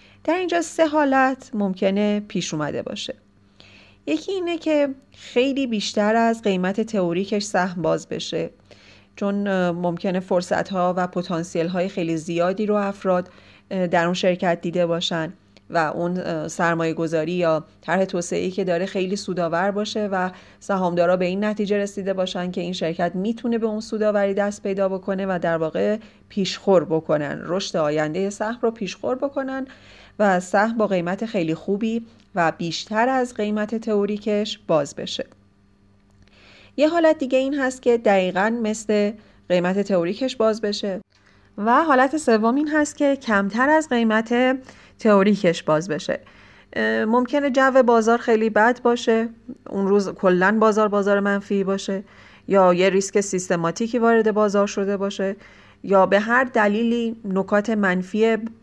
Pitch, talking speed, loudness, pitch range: 200 Hz, 140 wpm, -21 LUFS, 180-225 Hz